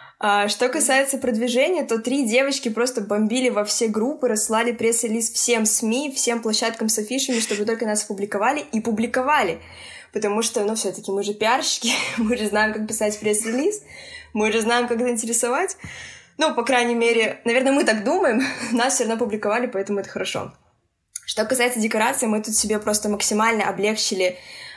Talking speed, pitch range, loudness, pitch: 165 wpm, 215-245 Hz, -21 LUFS, 230 Hz